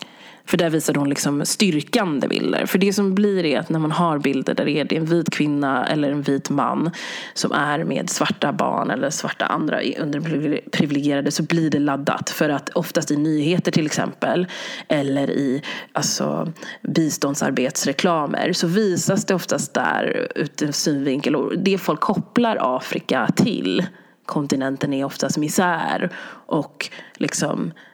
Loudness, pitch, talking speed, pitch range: -21 LUFS, 155 Hz, 150 wpm, 145-180 Hz